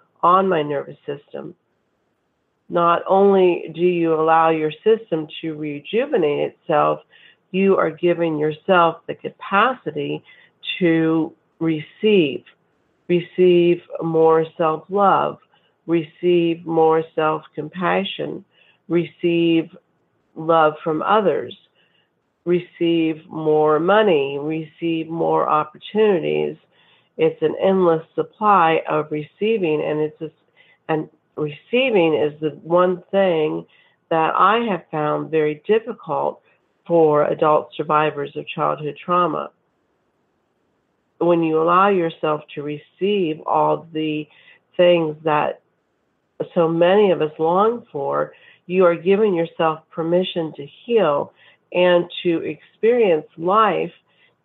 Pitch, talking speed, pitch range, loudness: 165 Hz, 100 wpm, 155-180 Hz, -19 LUFS